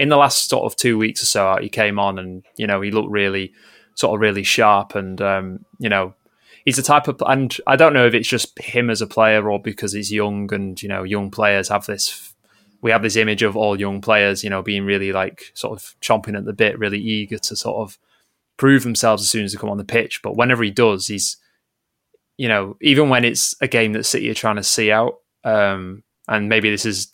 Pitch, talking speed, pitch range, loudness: 105 Hz, 245 wpm, 100-115 Hz, -18 LUFS